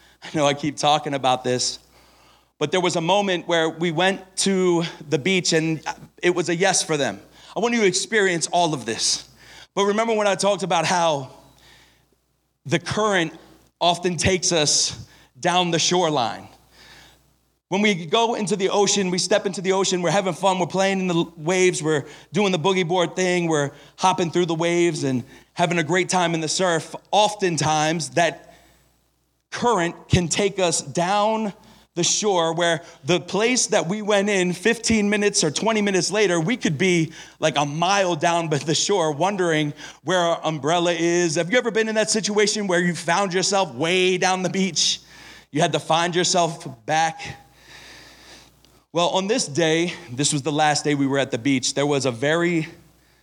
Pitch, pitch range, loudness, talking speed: 175 Hz, 155-190 Hz, -21 LUFS, 185 wpm